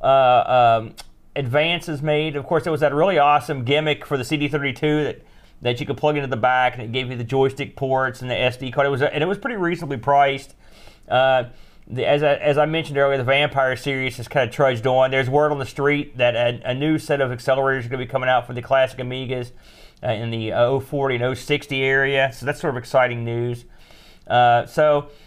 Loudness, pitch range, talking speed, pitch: -20 LUFS, 125-145 Hz, 230 wpm, 135 Hz